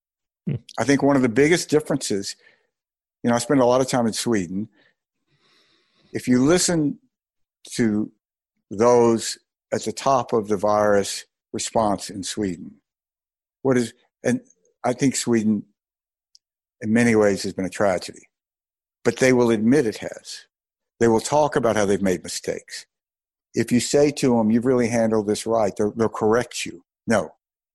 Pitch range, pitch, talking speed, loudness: 105-140 Hz, 120 Hz, 155 wpm, -21 LUFS